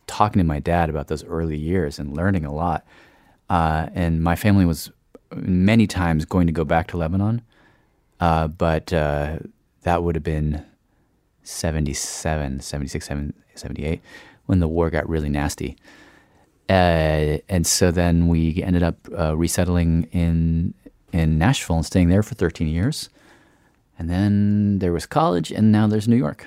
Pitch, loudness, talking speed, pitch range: 85 Hz, -21 LUFS, 155 wpm, 80-90 Hz